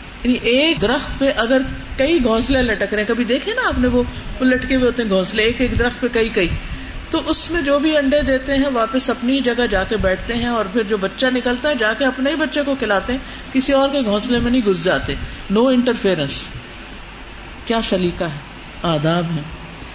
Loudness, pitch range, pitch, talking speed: -18 LUFS, 215-270 Hz, 245 Hz, 215 wpm